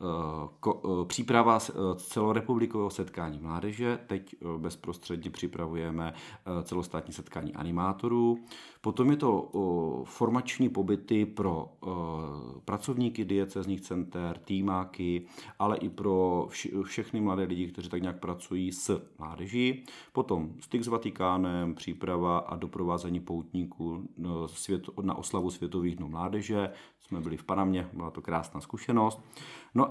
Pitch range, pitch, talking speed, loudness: 85-105 Hz, 90 Hz, 110 wpm, -32 LUFS